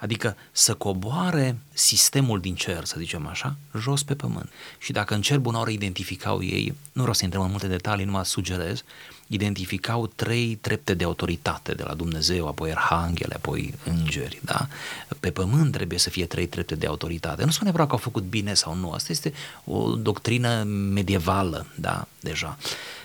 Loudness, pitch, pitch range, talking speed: -25 LUFS, 100 Hz, 90-120 Hz, 175 wpm